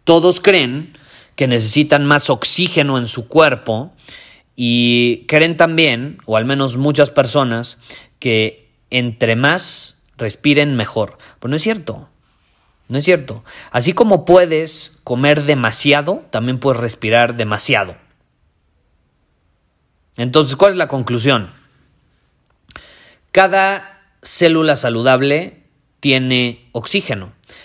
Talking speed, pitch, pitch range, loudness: 105 wpm, 135 Hz, 120-155 Hz, -14 LUFS